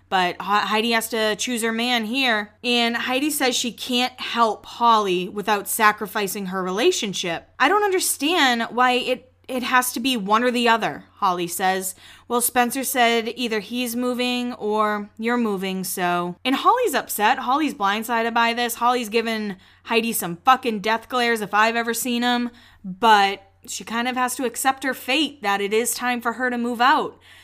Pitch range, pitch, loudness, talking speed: 210-250 Hz, 235 Hz, -21 LUFS, 175 wpm